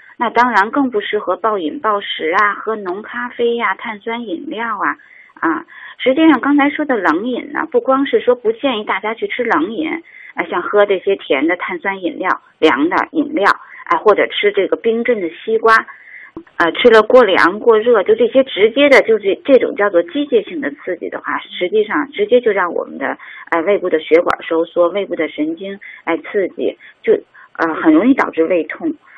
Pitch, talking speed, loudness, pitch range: 245 Hz, 285 characters per minute, -15 LUFS, 205-320 Hz